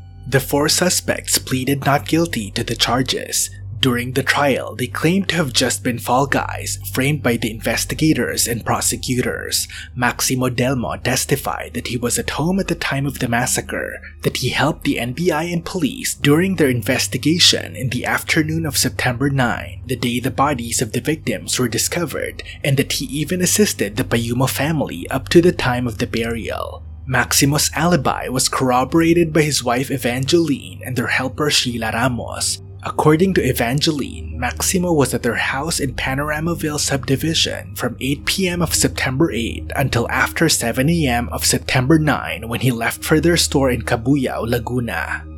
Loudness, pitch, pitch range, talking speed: -18 LUFS, 130 Hz, 115-150 Hz, 165 wpm